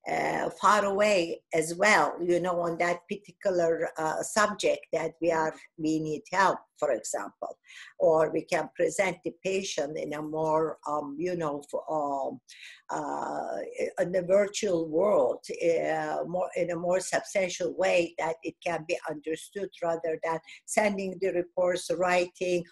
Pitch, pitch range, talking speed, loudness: 175 Hz, 160-190 Hz, 150 wpm, -29 LUFS